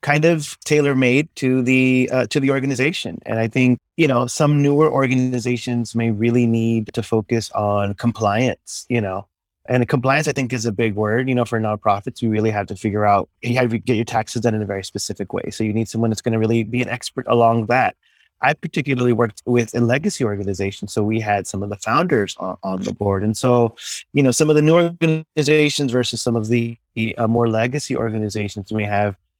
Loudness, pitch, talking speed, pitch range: -19 LUFS, 120 Hz, 220 wpm, 110-130 Hz